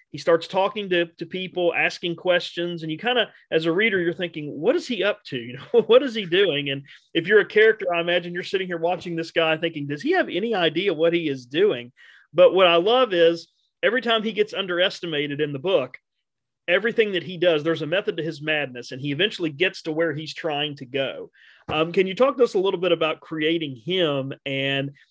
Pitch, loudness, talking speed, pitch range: 170 Hz, -22 LUFS, 230 wpm, 155-190 Hz